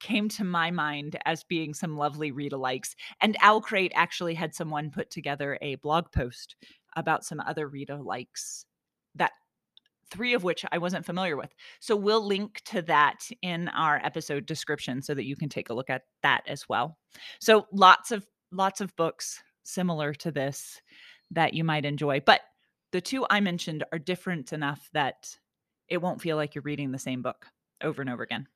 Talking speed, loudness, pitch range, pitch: 180 wpm, -28 LUFS, 145-185 Hz, 160 Hz